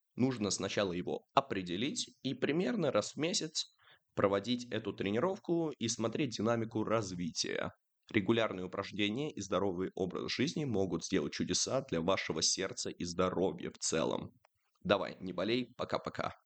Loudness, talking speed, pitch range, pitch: -35 LUFS, 130 wpm, 95-120 Hz, 105 Hz